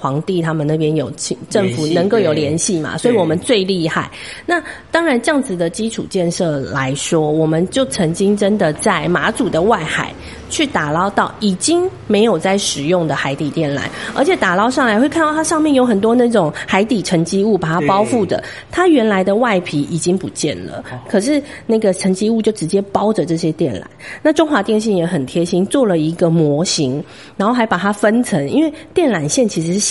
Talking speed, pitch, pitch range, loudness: 300 characters per minute, 195 Hz, 165-235 Hz, -16 LUFS